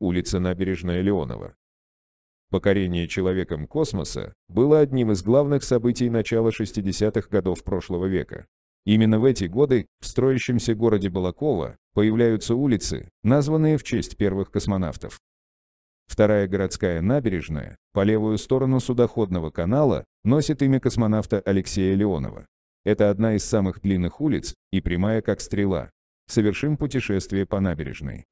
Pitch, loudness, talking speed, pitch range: 100 Hz, -23 LUFS, 125 wpm, 90-115 Hz